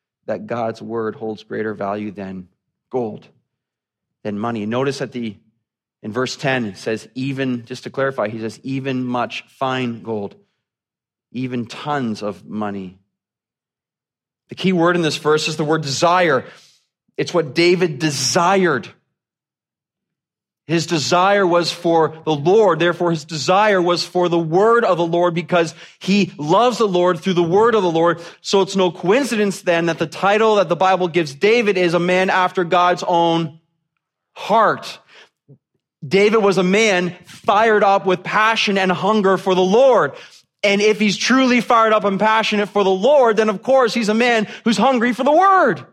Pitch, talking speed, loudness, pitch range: 175 Hz, 165 wpm, -17 LUFS, 130-195 Hz